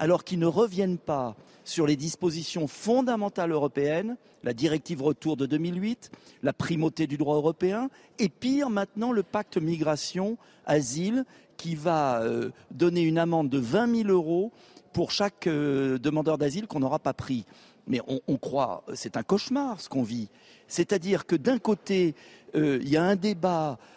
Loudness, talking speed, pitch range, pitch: -28 LUFS, 165 wpm, 150-200 Hz, 165 Hz